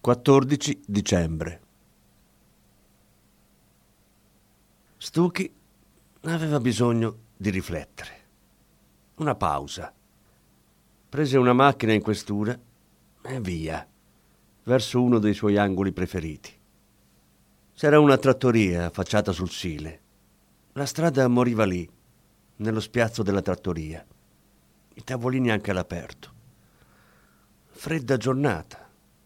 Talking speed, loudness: 85 wpm, -24 LUFS